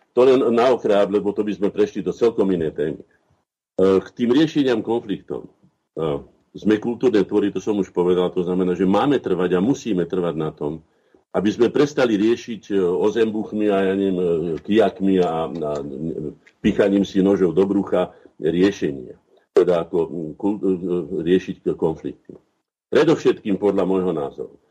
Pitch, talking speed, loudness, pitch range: 95 Hz, 140 wpm, -20 LUFS, 90-105 Hz